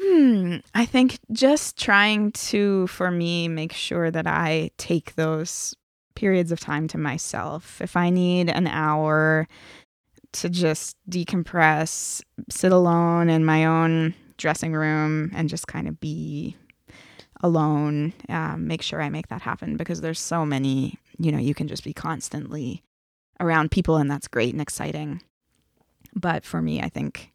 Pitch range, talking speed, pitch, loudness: 155-180 Hz, 155 wpm, 165 Hz, -23 LUFS